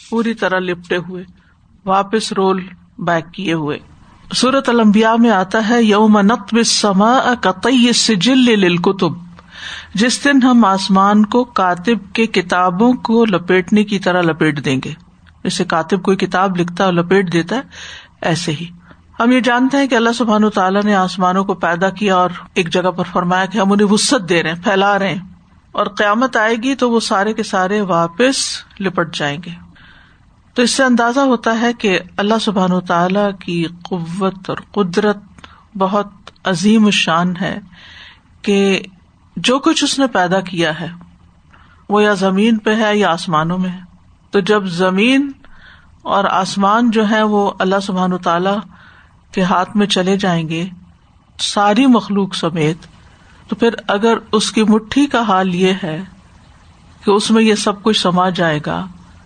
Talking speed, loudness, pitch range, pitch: 165 wpm, -14 LUFS, 180-220 Hz, 195 Hz